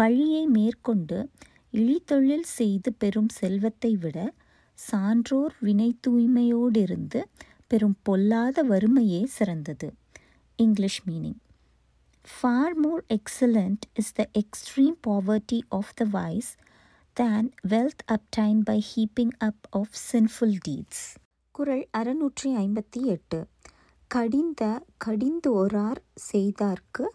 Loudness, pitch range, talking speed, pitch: -26 LUFS, 205-250 Hz, 95 wpm, 220 Hz